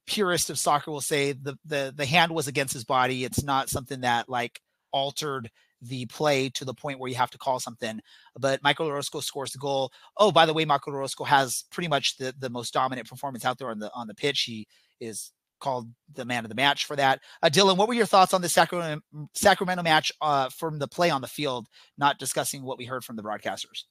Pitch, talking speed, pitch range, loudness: 140 Hz, 235 wpm, 130-155 Hz, -26 LUFS